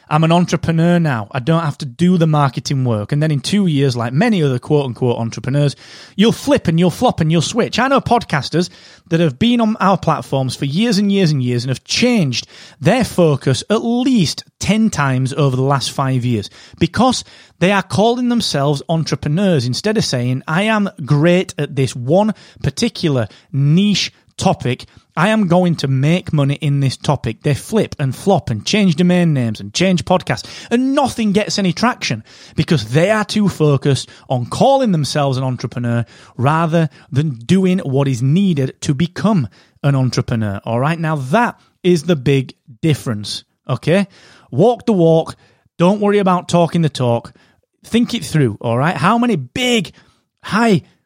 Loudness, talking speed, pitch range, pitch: -16 LUFS, 175 wpm, 135-190 Hz, 155 Hz